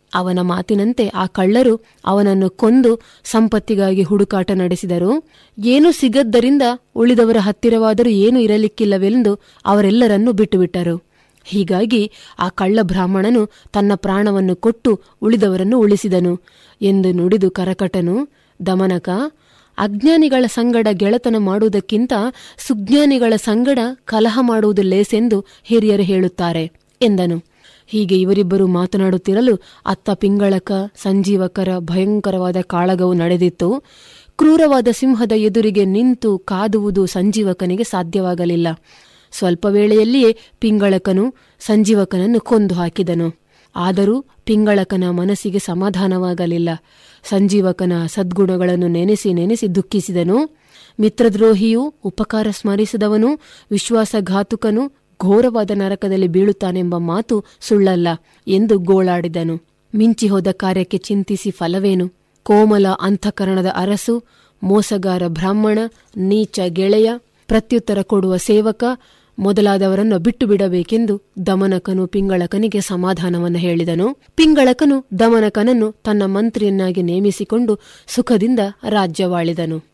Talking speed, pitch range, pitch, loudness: 85 wpm, 185-225 Hz, 200 Hz, -16 LUFS